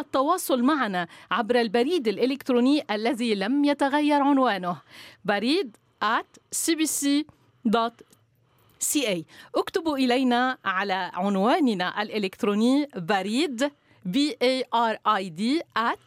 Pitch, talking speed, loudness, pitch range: 245 Hz, 80 wpm, -25 LUFS, 200-285 Hz